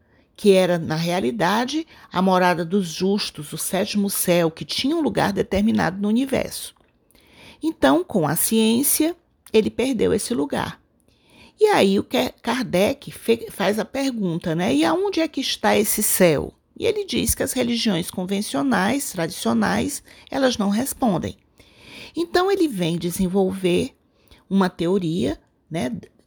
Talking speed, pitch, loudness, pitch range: 135 wpm, 210 Hz, -21 LUFS, 185-265 Hz